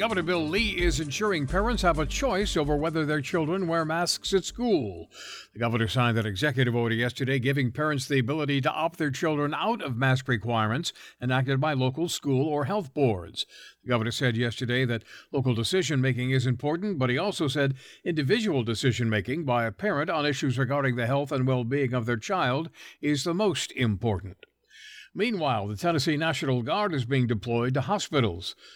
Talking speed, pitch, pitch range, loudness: 185 wpm, 140 Hz, 125-165 Hz, -27 LUFS